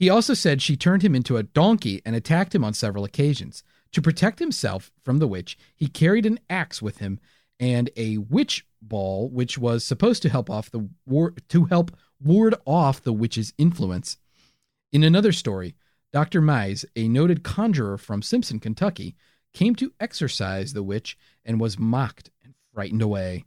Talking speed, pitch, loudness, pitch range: 175 wpm, 130 Hz, -23 LUFS, 110-170 Hz